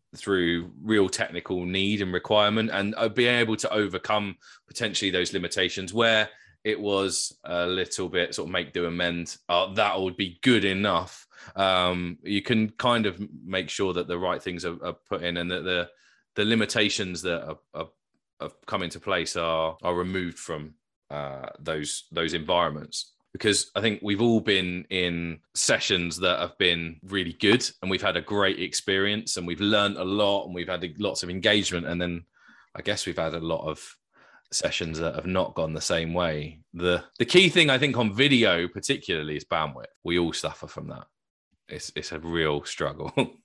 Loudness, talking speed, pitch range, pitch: -26 LUFS, 185 wpm, 85-105 Hz, 90 Hz